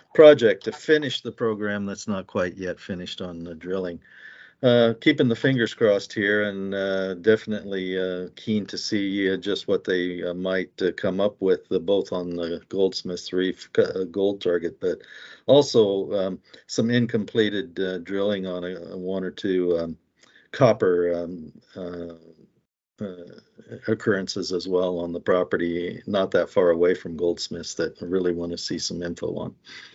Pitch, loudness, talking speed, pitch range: 95 Hz, -24 LUFS, 170 wpm, 90-105 Hz